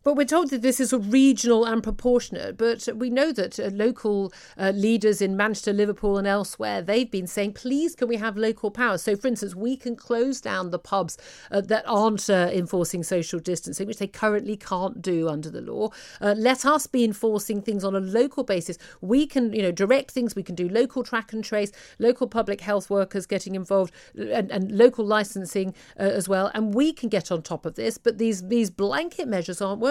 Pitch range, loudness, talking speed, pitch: 195-240 Hz, -24 LUFS, 215 wpm, 215 Hz